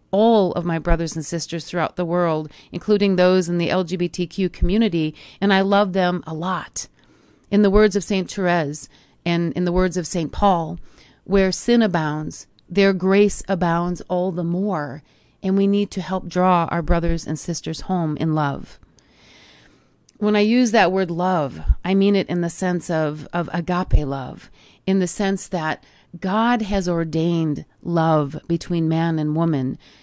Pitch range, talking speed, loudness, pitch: 165-195 Hz, 170 wpm, -21 LUFS, 175 Hz